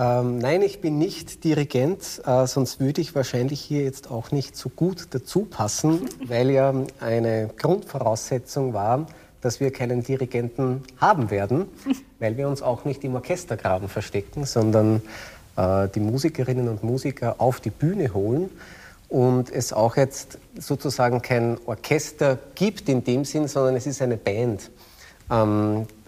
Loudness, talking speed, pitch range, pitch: -24 LUFS, 140 wpm, 115-145 Hz, 130 Hz